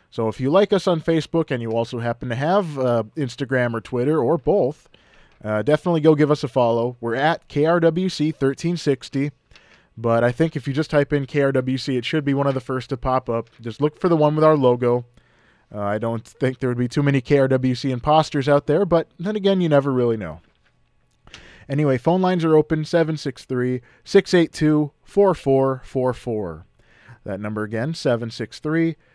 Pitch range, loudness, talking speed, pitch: 120-155 Hz, -21 LUFS, 180 wpm, 135 Hz